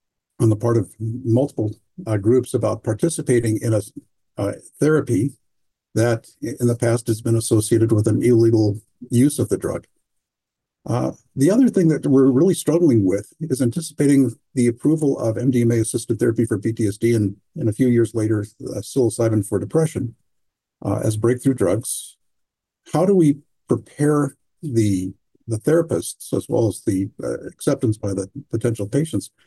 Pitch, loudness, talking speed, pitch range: 120 Hz, -20 LUFS, 155 wpm, 110-135 Hz